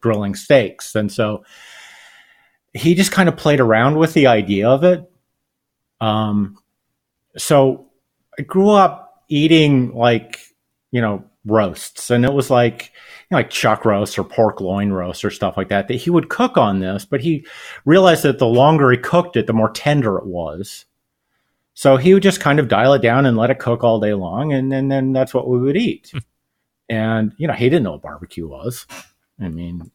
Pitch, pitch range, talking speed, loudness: 125 Hz, 105-145 Hz, 195 wpm, -16 LUFS